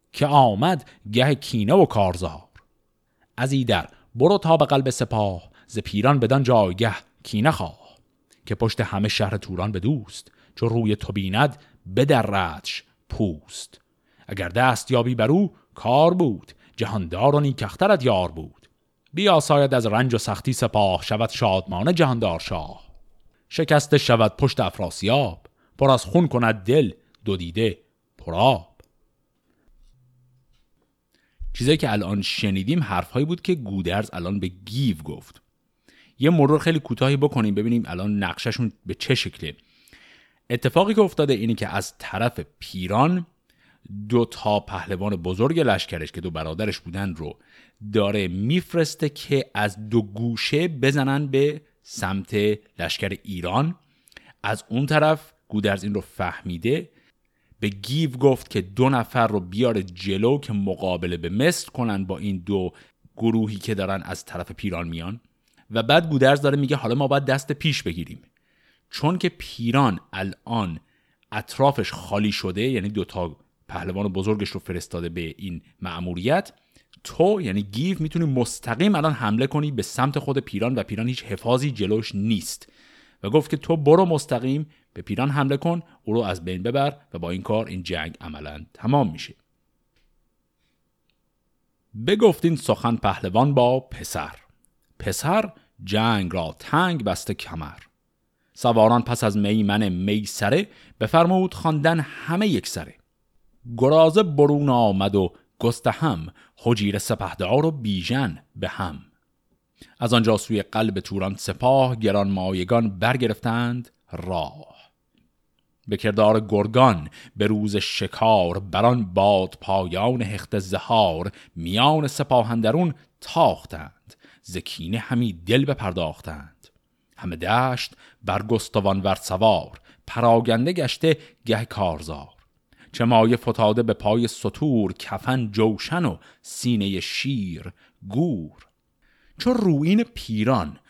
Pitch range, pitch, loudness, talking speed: 100-135 Hz, 115 Hz, -22 LUFS, 130 wpm